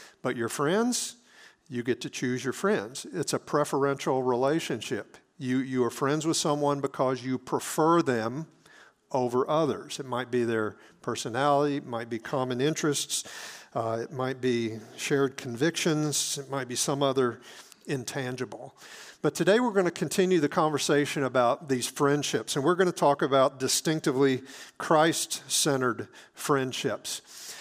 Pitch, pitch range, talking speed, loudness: 140 Hz, 125-150 Hz, 150 wpm, -28 LUFS